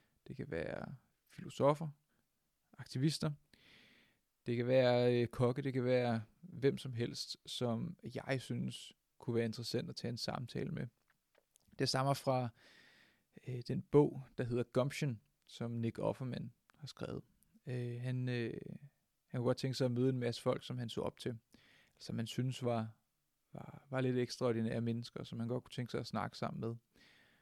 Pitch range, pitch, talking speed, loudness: 120-135 Hz, 125 Hz, 170 wpm, -39 LUFS